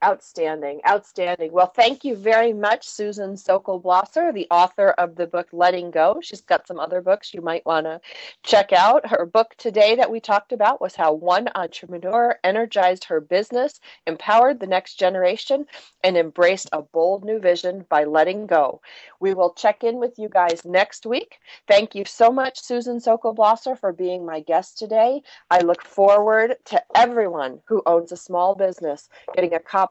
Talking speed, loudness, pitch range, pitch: 180 wpm, -20 LUFS, 175-225 Hz, 195 Hz